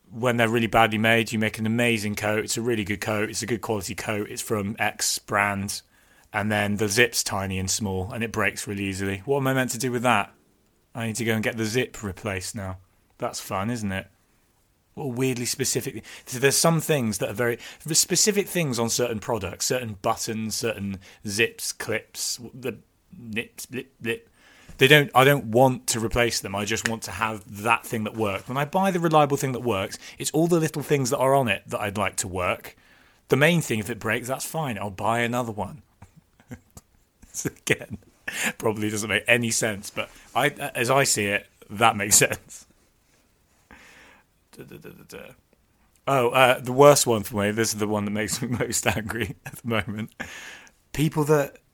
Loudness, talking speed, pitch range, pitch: -24 LUFS, 195 wpm, 105-130 Hz, 115 Hz